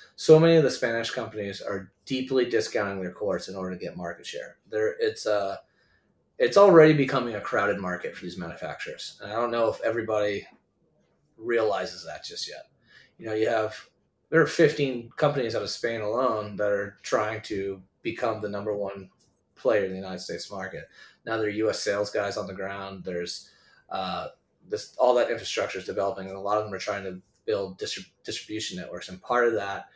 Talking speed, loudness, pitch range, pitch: 200 wpm, -27 LUFS, 95-125 Hz, 105 Hz